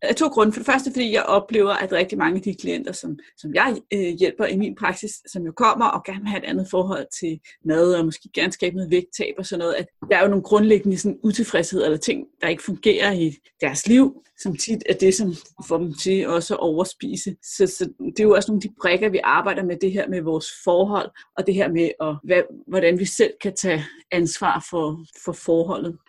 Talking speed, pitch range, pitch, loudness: 240 wpm, 170-210 Hz, 190 Hz, -21 LUFS